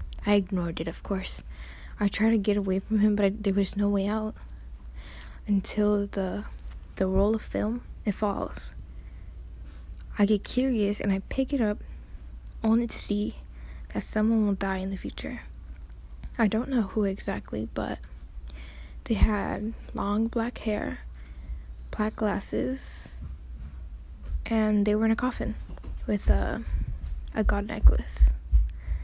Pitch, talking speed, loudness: 190 Hz, 145 wpm, -28 LUFS